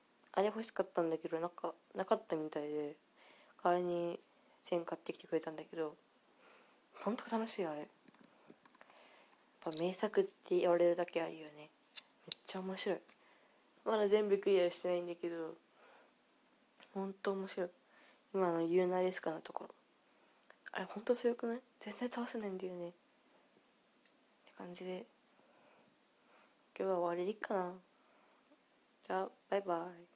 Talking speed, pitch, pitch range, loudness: 290 characters per minute, 185 Hz, 175-215 Hz, -39 LUFS